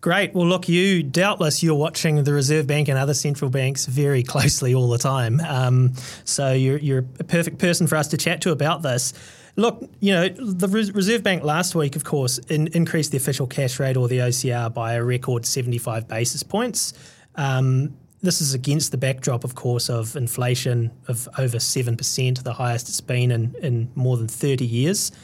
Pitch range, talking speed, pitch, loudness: 125-160 Hz, 195 wpm, 135 Hz, -21 LUFS